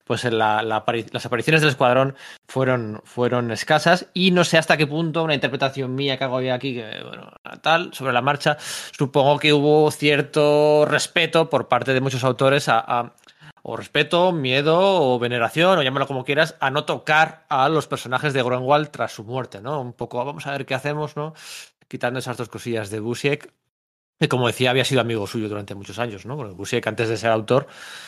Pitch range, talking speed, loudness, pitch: 120-150 Hz, 200 wpm, -20 LUFS, 135 Hz